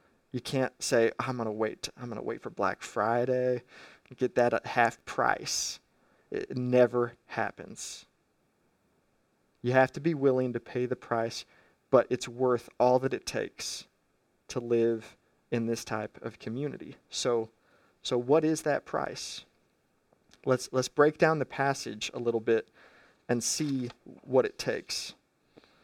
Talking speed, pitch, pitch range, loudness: 155 wpm, 125 Hz, 115-130 Hz, -30 LUFS